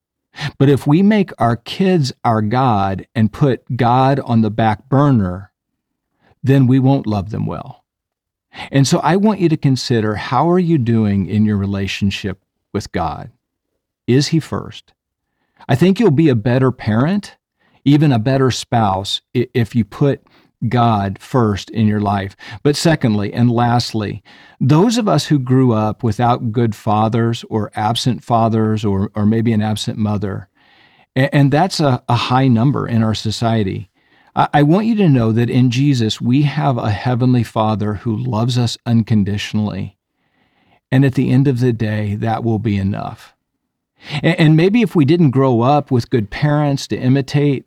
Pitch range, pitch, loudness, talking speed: 110-140 Hz, 120 Hz, -16 LUFS, 165 wpm